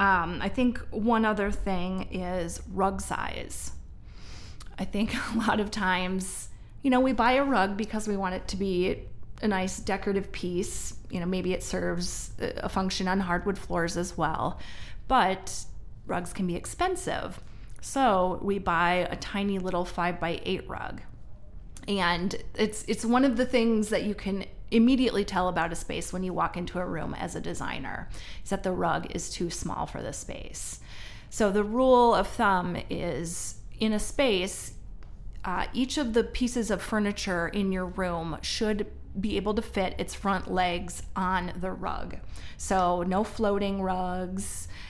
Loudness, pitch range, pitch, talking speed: -29 LUFS, 180-215 Hz, 190 Hz, 165 wpm